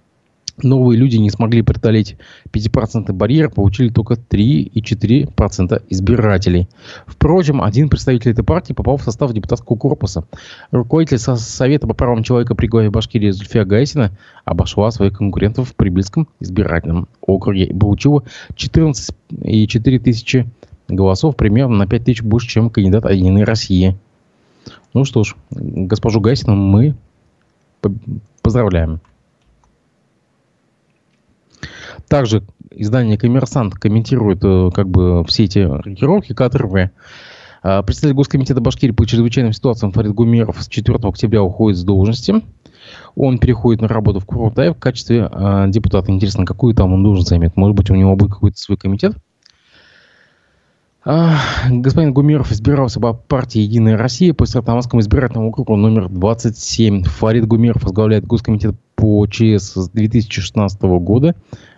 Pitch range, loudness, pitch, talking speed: 100-125 Hz, -14 LUFS, 110 Hz, 125 wpm